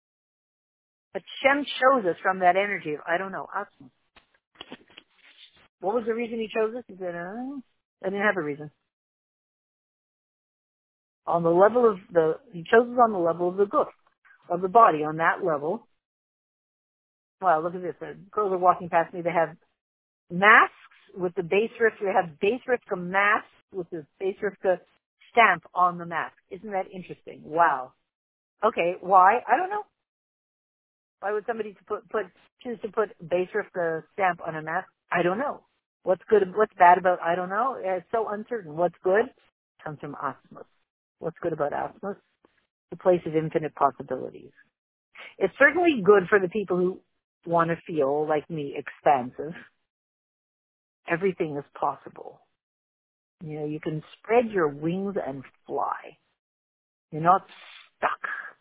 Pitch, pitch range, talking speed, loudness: 185 Hz, 170-210 Hz, 165 wpm, -25 LUFS